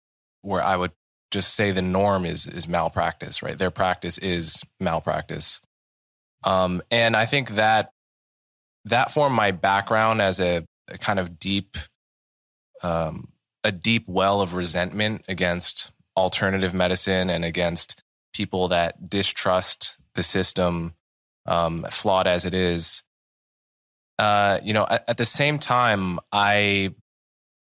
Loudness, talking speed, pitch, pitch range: -22 LUFS, 130 wpm, 95 Hz, 90-100 Hz